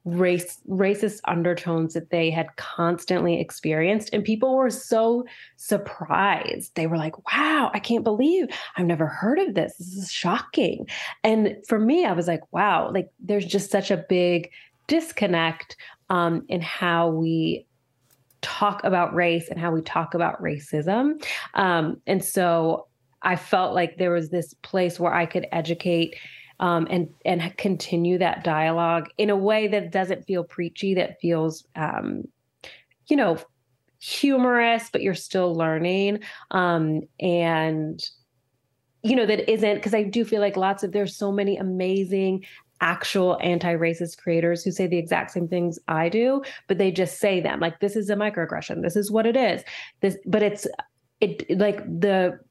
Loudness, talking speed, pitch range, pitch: -24 LUFS, 160 wpm, 170-205 Hz, 180 Hz